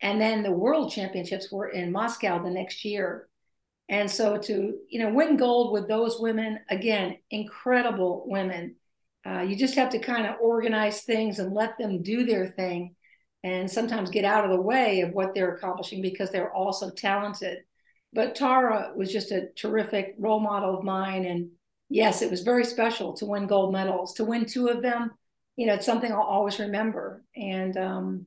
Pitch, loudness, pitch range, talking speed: 205 Hz, -27 LUFS, 190-225 Hz, 185 wpm